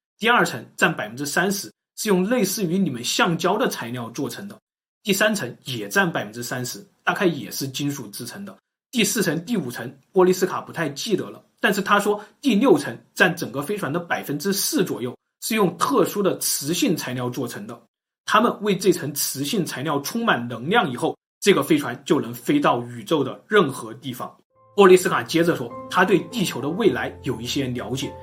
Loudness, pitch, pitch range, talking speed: -22 LUFS, 170 Hz, 130-195 Hz, 295 characters per minute